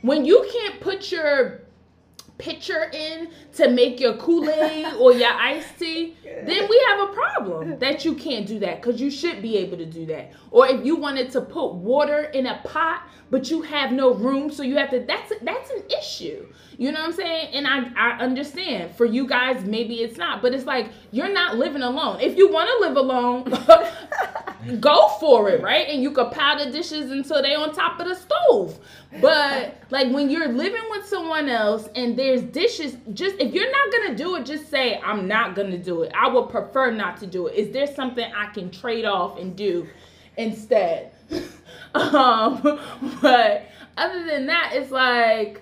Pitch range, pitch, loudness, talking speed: 245-325 Hz, 280 Hz, -21 LUFS, 195 wpm